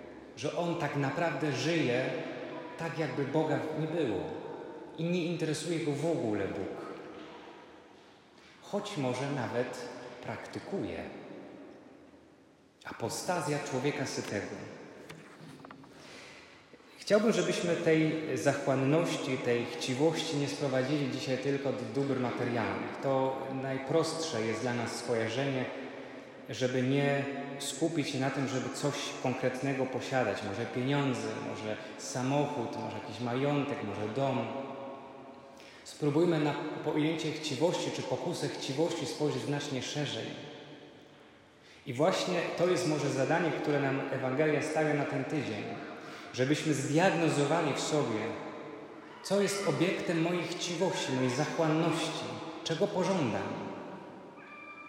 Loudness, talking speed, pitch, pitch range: -32 LUFS, 105 wpm, 145 Hz, 130-160 Hz